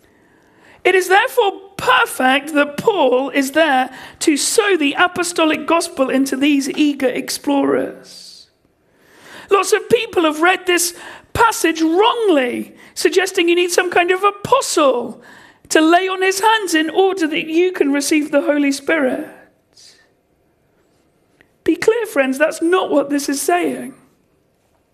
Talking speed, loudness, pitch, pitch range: 130 wpm, -16 LUFS, 340 Hz, 290-380 Hz